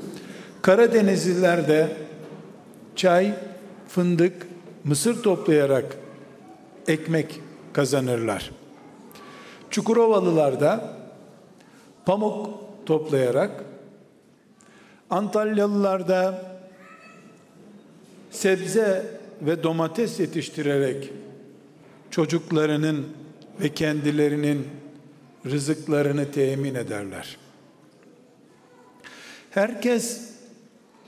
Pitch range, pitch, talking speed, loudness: 150-210 Hz, 180 Hz, 50 wpm, -23 LUFS